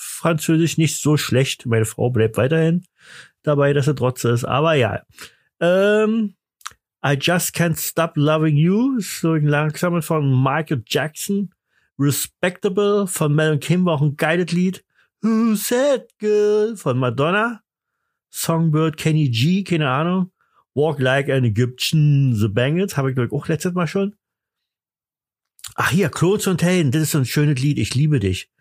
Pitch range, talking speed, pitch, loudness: 140-185 Hz, 150 wpm, 160 Hz, -19 LUFS